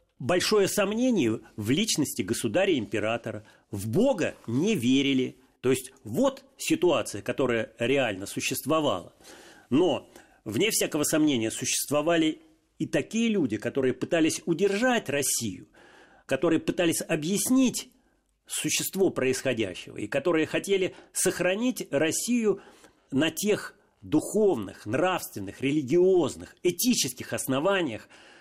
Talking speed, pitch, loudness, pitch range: 95 wpm, 160 Hz, -27 LUFS, 130-205 Hz